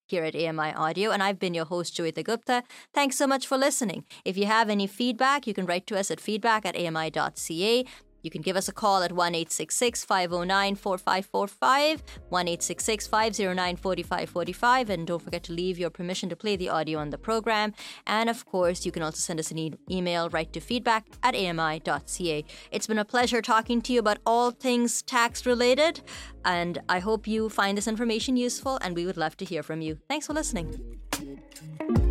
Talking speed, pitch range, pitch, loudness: 185 wpm, 170-235 Hz, 195 Hz, -27 LUFS